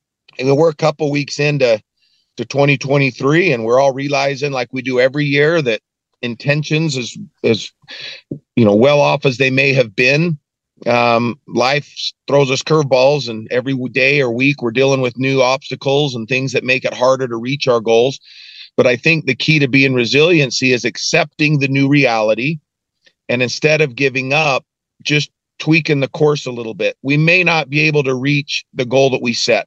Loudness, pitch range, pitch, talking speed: -14 LUFS, 125-145 Hz, 135 Hz, 190 wpm